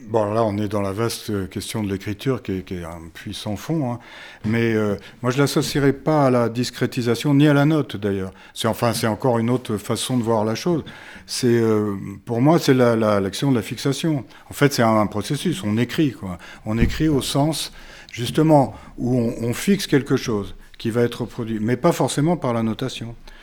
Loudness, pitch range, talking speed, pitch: -21 LUFS, 105-140 Hz, 220 wpm, 120 Hz